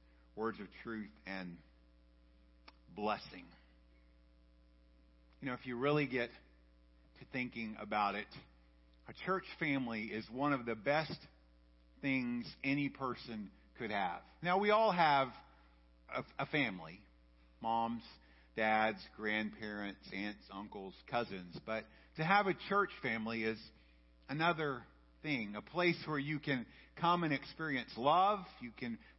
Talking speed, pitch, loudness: 125 wpm, 110 Hz, -38 LUFS